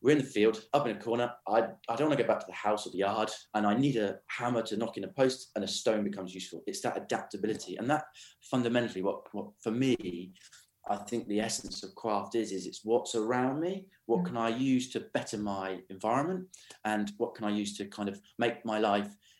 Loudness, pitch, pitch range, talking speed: -32 LUFS, 110 Hz, 100-120 Hz, 240 wpm